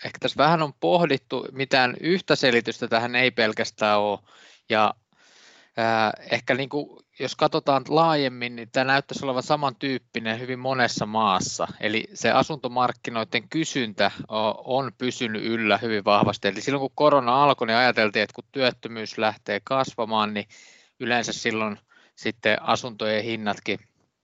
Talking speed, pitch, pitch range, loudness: 140 wpm, 120 Hz, 110-135 Hz, -24 LUFS